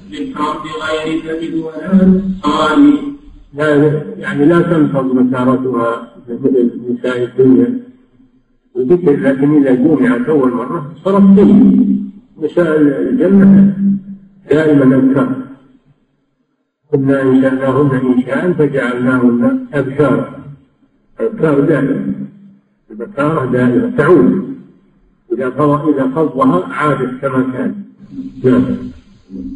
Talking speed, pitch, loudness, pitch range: 80 wpm, 145 Hz, -12 LUFS, 130-190 Hz